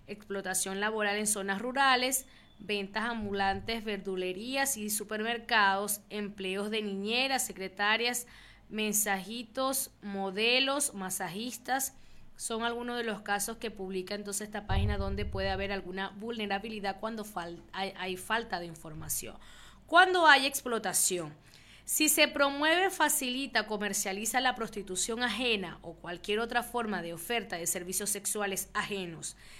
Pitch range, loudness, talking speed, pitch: 190-235 Hz, -31 LUFS, 120 wpm, 210 Hz